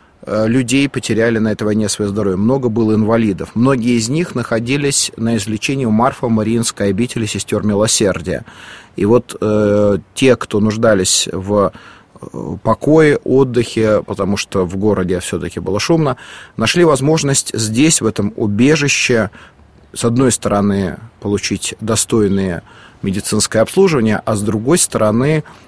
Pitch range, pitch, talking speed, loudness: 105-125 Hz, 110 Hz, 130 wpm, -15 LUFS